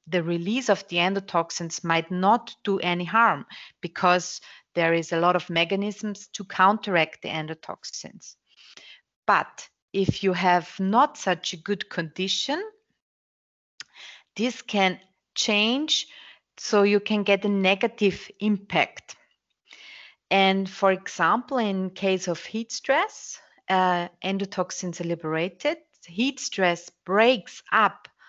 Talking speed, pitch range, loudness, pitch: 120 wpm, 180-215 Hz, -24 LUFS, 190 Hz